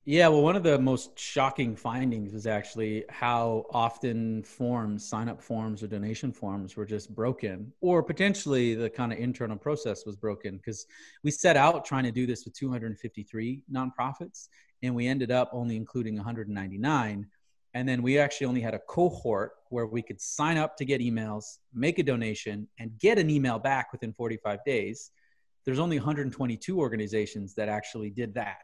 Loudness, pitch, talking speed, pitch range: -29 LUFS, 120 Hz, 175 wpm, 110-135 Hz